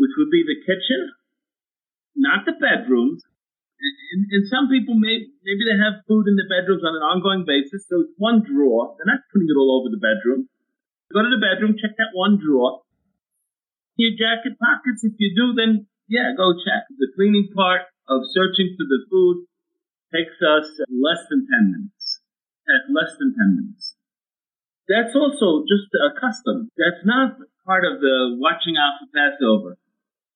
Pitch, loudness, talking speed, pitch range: 215 Hz, -19 LUFS, 170 wpm, 185-260 Hz